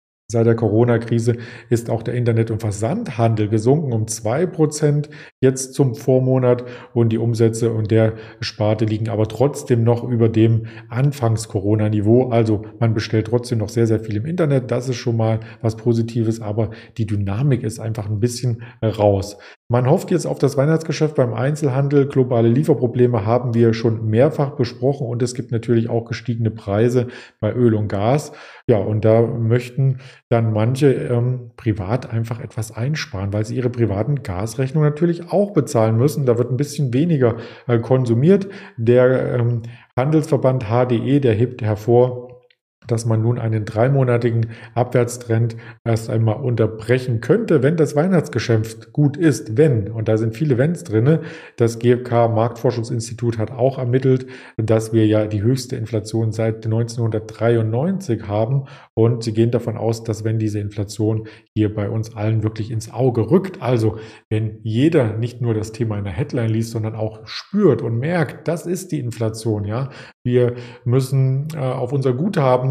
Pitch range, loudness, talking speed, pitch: 110-130 Hz, -19 LUFS, 160 wpm, 120 Hz